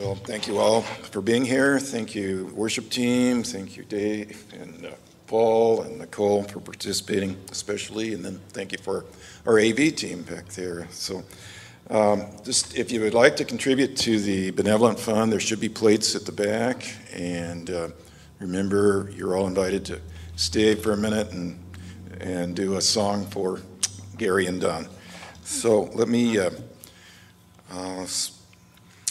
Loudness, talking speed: -24 LUFS, 160 wpm